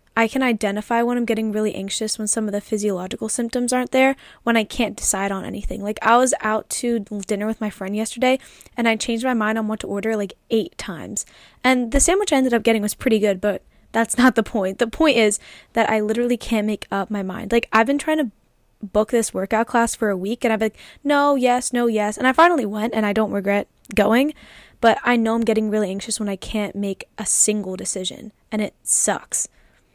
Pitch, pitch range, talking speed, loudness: 220 Hz, 210-240 Hz, 230 wpm, -20 LUFS